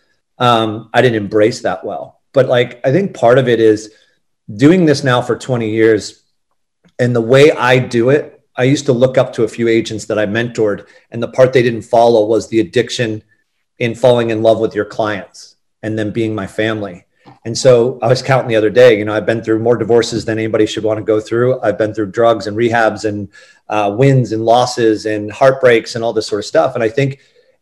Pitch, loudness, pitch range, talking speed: 115 Hz, -13 LUFS, 110-125 Hz, 220 wpm